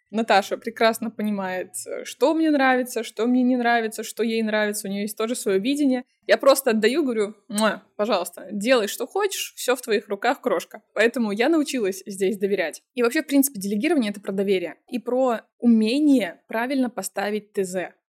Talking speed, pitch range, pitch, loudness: 170 wpm, 205-255 Hz, 225 Hz, -23 LUFS